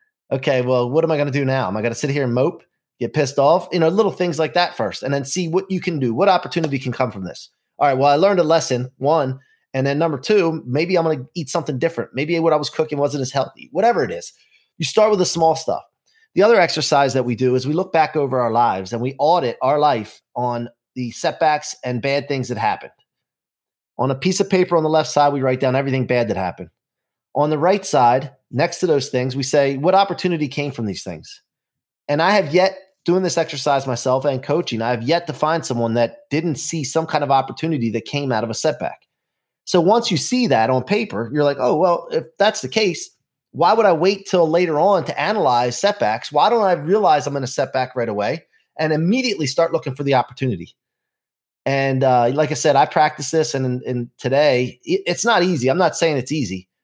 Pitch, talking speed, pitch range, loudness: 145 Hz, 235 wpm, 130-170 Hz, -19 LUFS